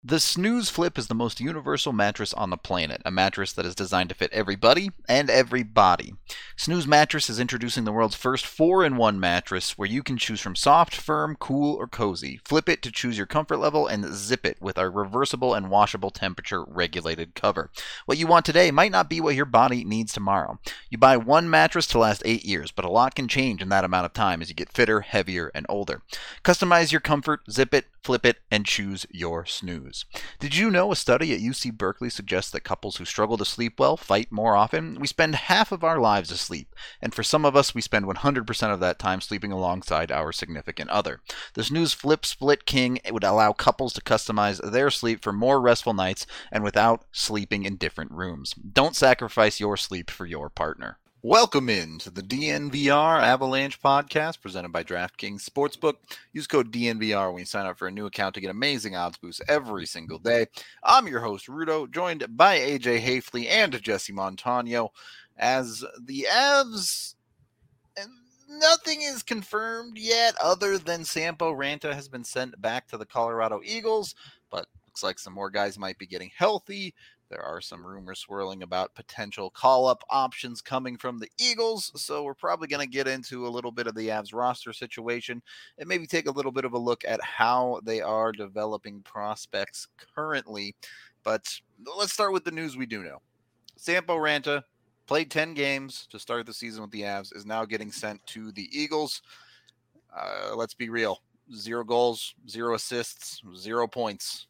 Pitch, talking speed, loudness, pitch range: 120 Hz, 190 wpm, -24 LUFS, 100-145 Hz